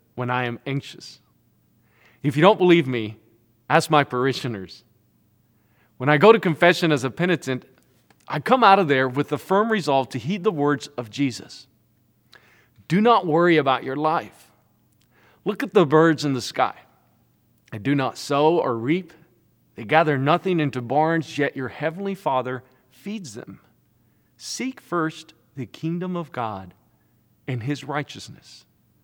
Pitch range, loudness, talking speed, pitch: 125-165 Hz, -21 LUFS, 155 wpm, 145 Hz